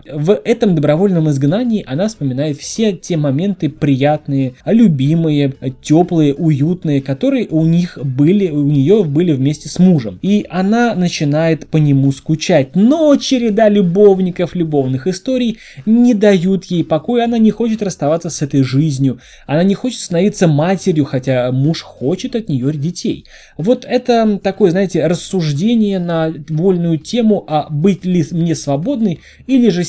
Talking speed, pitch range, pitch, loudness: 145 wpm, 150-205 Hz, 170 Hz, -14 LUFS